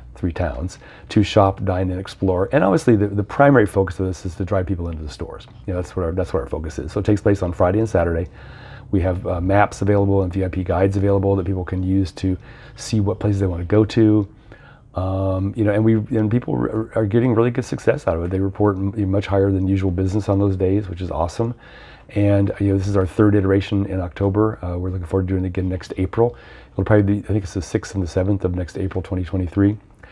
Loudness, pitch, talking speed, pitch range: -20 LUFS, 95 Hz, 255 wpm, 95-105 Hz